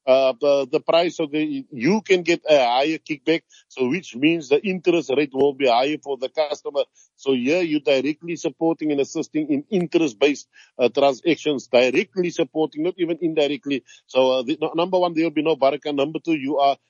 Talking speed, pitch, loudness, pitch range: 190 wpm, 155 Hz, -21 LUFS, 140-170 Hz